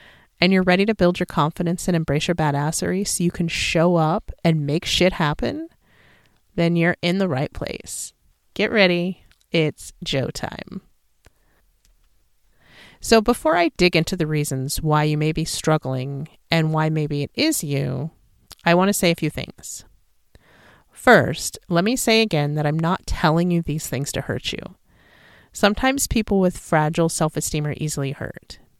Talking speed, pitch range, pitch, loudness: 165 wpm, 150-180 Hz, 165 Hz, -21 LUFS